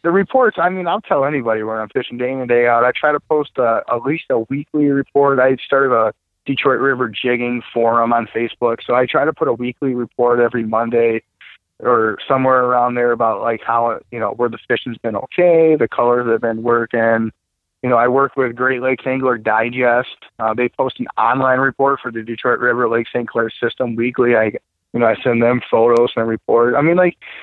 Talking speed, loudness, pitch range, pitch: 220 wpm, -16 LUFS, 115-135 Hz, 120 Hz